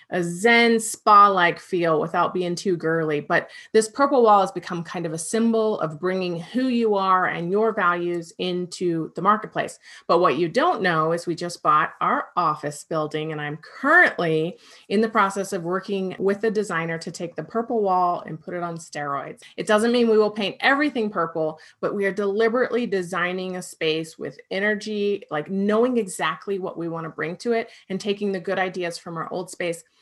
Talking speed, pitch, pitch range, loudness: 200 wpm, 185 Hz, 170-215 Hz, -22 LUFS